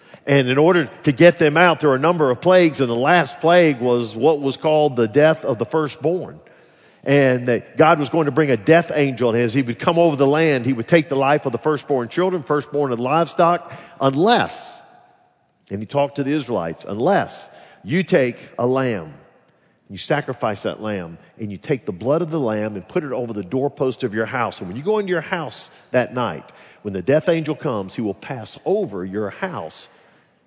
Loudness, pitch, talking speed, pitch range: -19 LUFS, 140 Hz, 215 wpm, 120-160 Hz